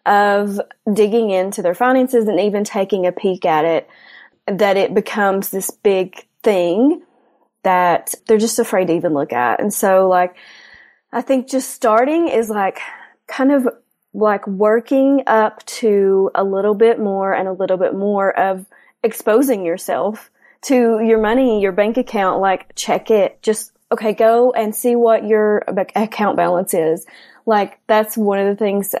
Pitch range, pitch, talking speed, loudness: 195-230 Hz, 210 Hz, 165 wpm, -16 LUFS